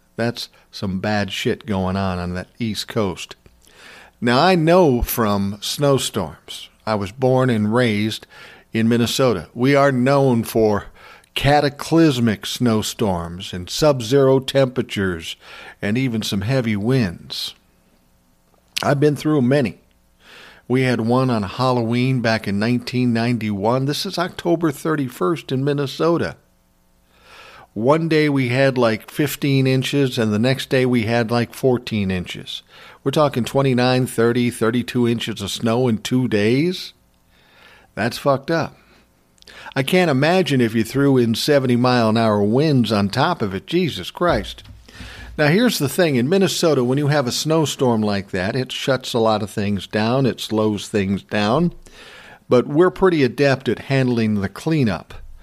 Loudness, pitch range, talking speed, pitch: -19 LUFS, 105-140 Hz, 145 wpm, 120 Hz